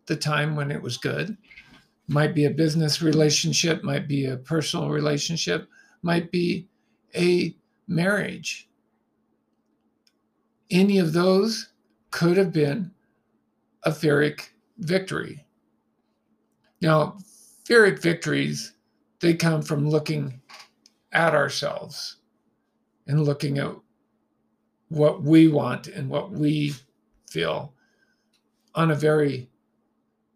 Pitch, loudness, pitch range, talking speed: 155 Hz, -23 LUFS, 145-175 Hz, 100 wpm